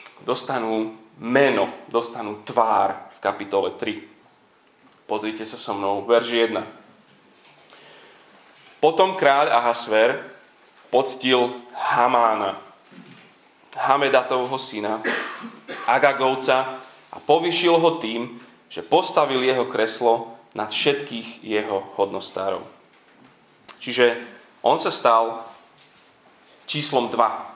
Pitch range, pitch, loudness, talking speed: 110-130 Hz, 120 Hz, -21 LUFS, 85 wpm